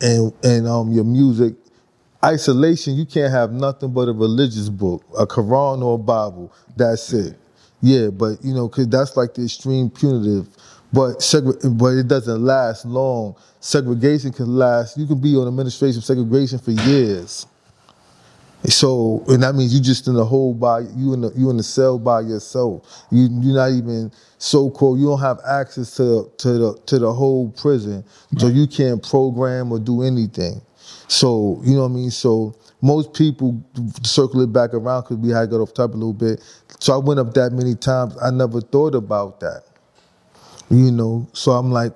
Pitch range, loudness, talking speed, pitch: 115-135 Hz, -18 LUFS, 190 wpm, 125 Hz